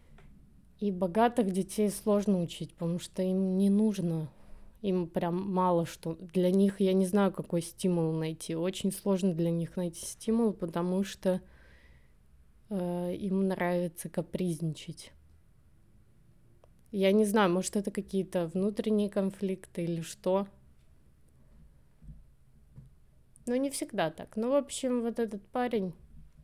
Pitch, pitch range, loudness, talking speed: 185 Hz, 160-200 Hz, -31 LUFS, 125 wpm